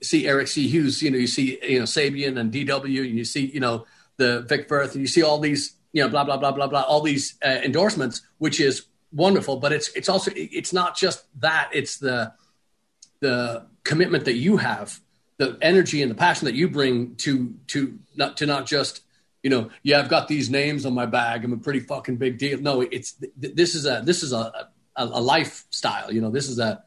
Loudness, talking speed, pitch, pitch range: -23 LUFS, 230 wpm, 140 Hz, 130-150 Hz